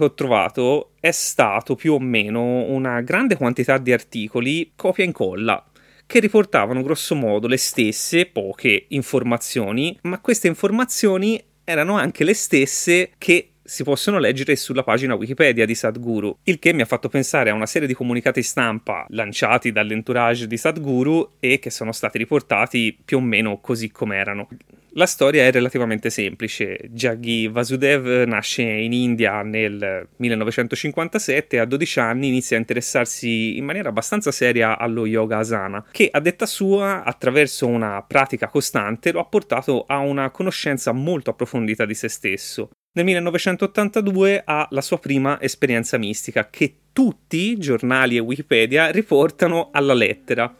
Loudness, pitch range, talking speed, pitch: -19 LUFS, 115-165 Hz, 150 wpm, 130 Hz